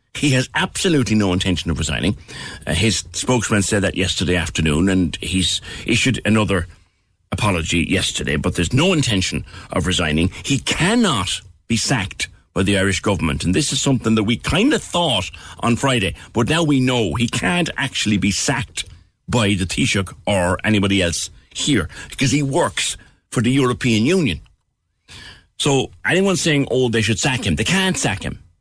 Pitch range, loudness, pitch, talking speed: 90-130 Hz, -18 LUFS, 105 Hz, 170 wpm